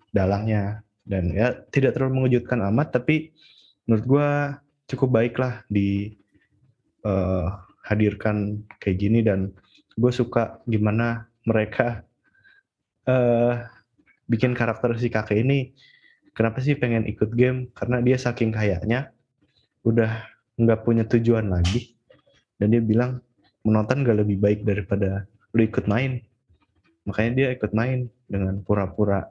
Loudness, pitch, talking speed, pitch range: -23 LUFS, 115 Hz, 125 wpm, 105-125 Hz